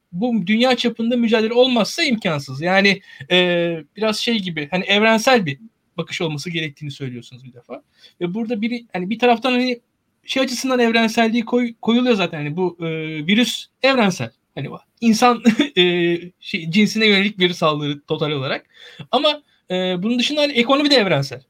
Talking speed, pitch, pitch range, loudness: 155 wpm, 210 Hz, 170-240 Hz, -18 LUFS